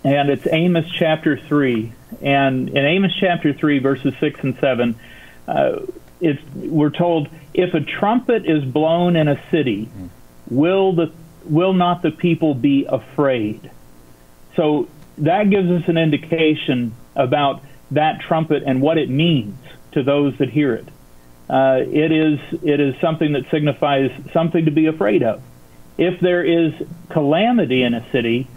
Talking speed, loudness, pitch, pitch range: 150 wpm, -18 LUFS, 150 Hz, 135-165 Hz